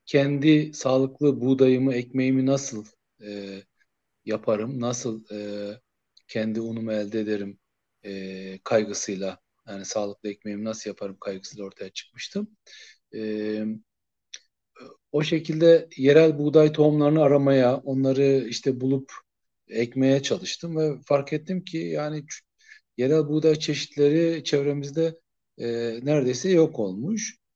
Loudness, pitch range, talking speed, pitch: -24 LUFS, 110-150 Hz, 105 wpm, 135 Hz